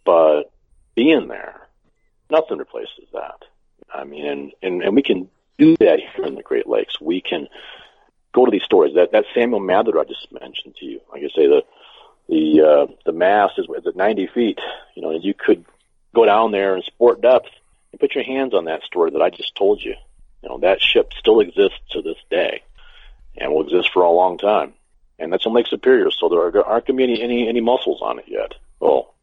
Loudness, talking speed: -17 LUFS, 215 wpm